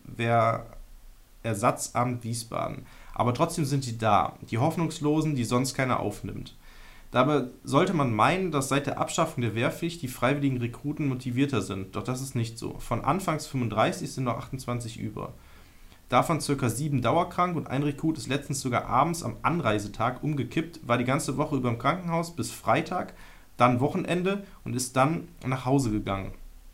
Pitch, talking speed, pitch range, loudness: 130 Hz, 160 wpm, 115-150 Hz, -28 LUFS